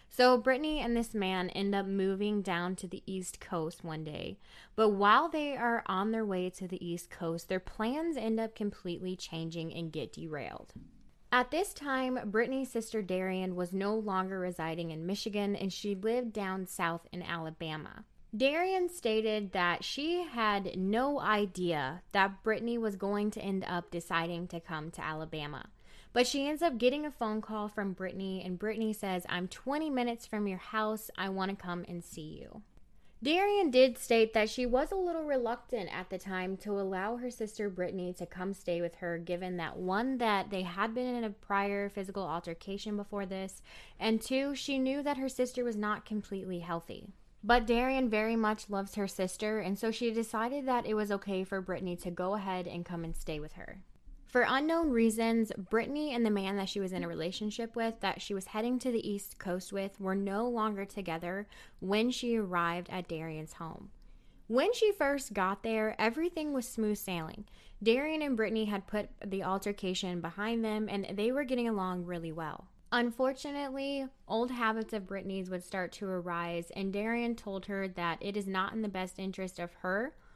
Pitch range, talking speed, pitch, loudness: 185-230 Hz, 190 wpm, 205 Hz, -34 LUFS